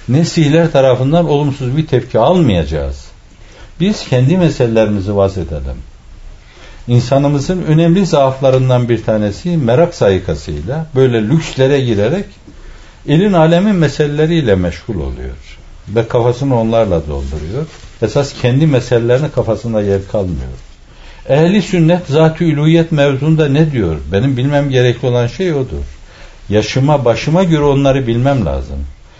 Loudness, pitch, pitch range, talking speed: -13 LUFS, 125 Hz, 100-150 Hz, 115 wpm